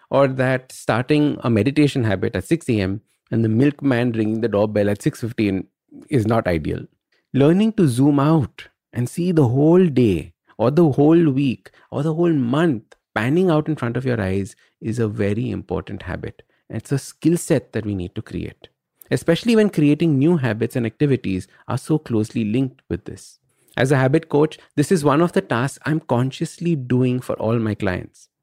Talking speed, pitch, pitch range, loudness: 185 wpm, 130 Hz, 110-155 Hz, -20 LUFS